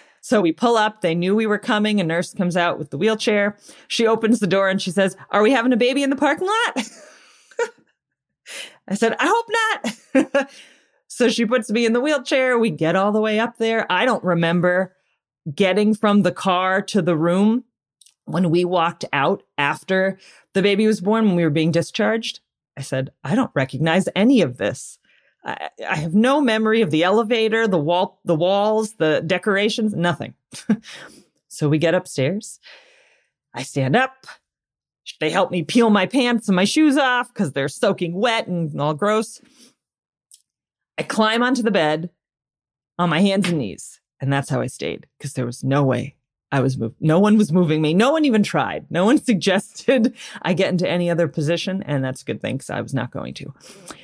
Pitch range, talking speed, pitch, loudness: 170-230 Hz, 190 wpm, 195 Hz, -19 LUFS